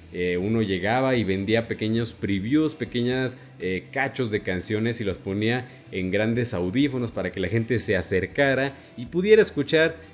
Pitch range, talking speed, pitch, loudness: 100-130 Hz, 160 wpm, 115 Hz, -24 LUFS